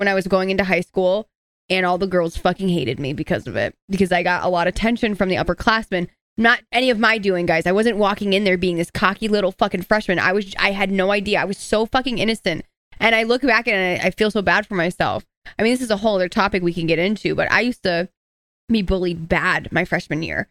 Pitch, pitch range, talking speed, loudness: 195 Hz, 180-215 Hz, 260 wpm, -19 LUFS